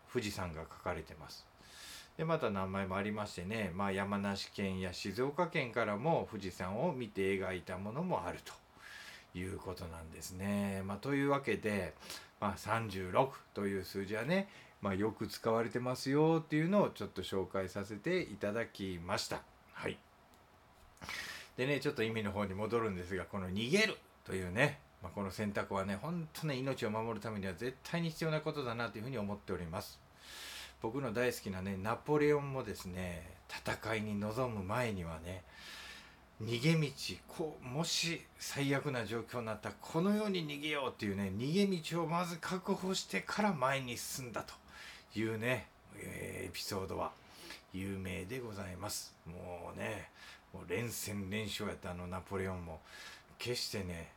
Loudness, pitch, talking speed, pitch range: -38 LUFS, 105 Hz, 325 characters per minute, 95-135 Hz